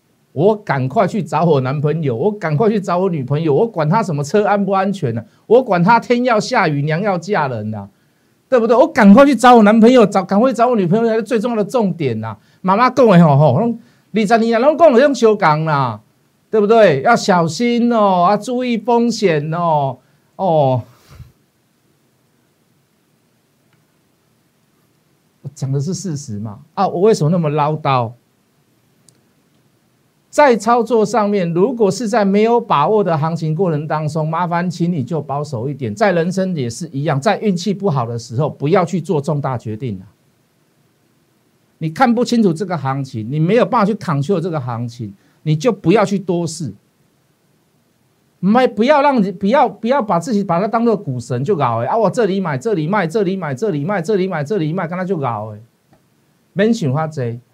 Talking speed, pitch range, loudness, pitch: 265 characters per minute, 145-215 Hz, -15 LUFS, 185 Hz